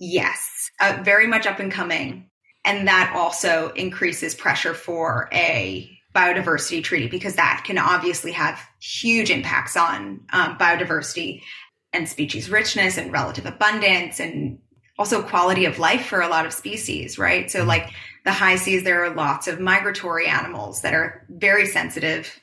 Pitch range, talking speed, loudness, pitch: 165-195 Hz, 155 wpm, -20 LUFS, 180 Hz